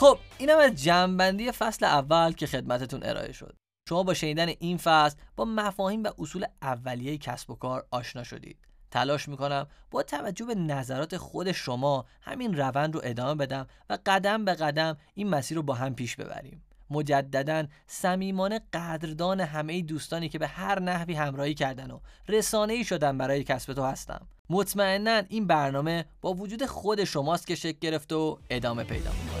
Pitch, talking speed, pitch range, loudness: 160 Hz, 170 wpm, 140-185 Hz, -28 LUFS